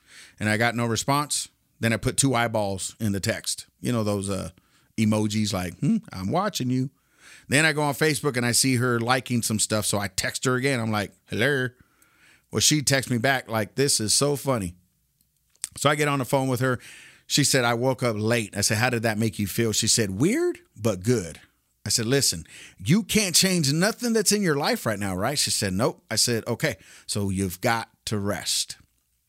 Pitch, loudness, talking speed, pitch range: 120 Hz, -24 LUFS, 215 wpm, 105-140 Hz